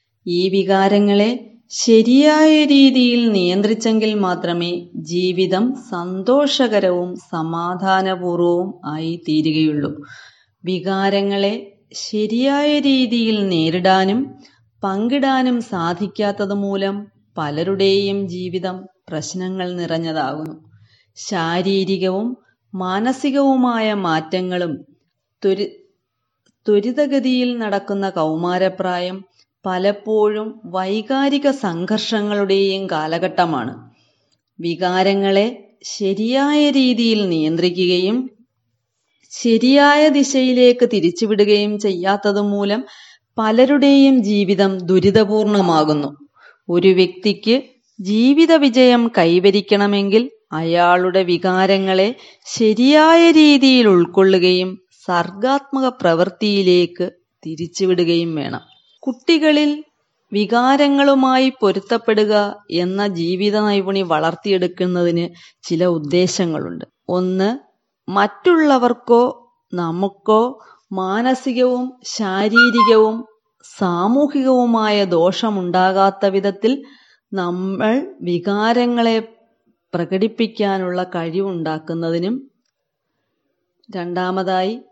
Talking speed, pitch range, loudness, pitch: 55 wpm, 180-235 Hz, -16 LUFS, 200 Hz